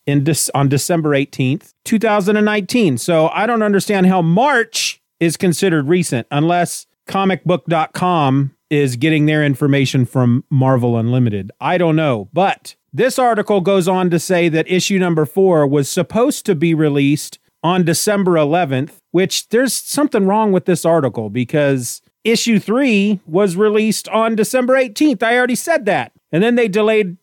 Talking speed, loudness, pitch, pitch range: 150 wpm, -15 LUFS, 180 Hz, 150-210 Hz